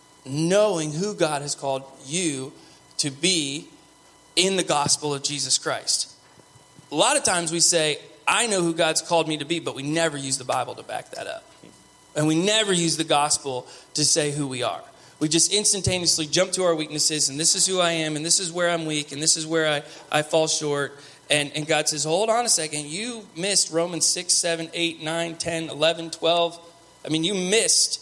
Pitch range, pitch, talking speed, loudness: 150-170 Hz, 160 Hz, 210 wpm, -22 LUFS